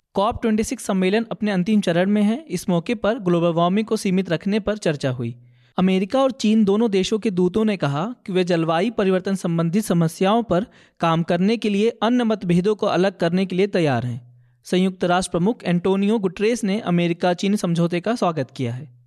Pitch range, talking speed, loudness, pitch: 175-215 Hz, 195 wpm, -21 LUFS, 190 Hz